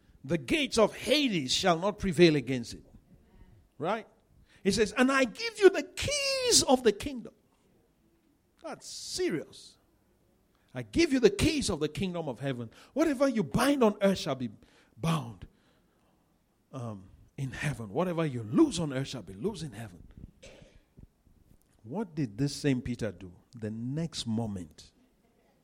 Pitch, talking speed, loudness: 155 Hz, 145 wpm, -29 LUFS